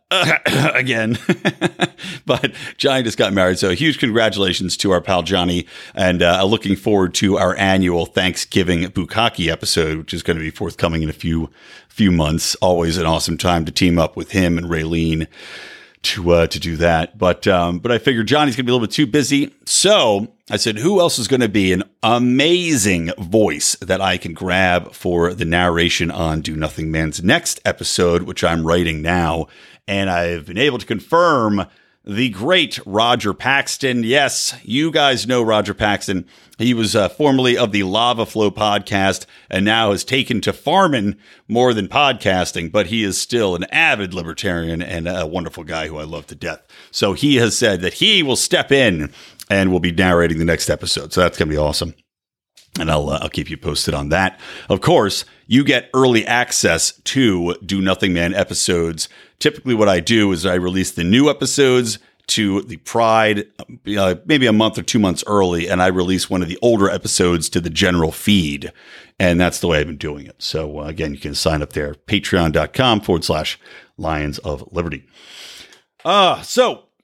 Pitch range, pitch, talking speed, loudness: 85-110 Hz, 95 Hz, 190 wpm, -17 LUFS